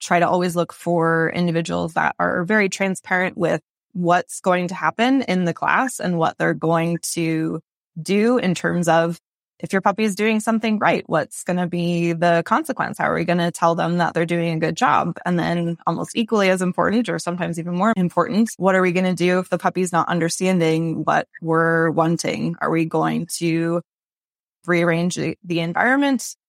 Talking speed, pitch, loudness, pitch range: 195 wpm, 175 Hz, -20 LUFS, 165-185 Hz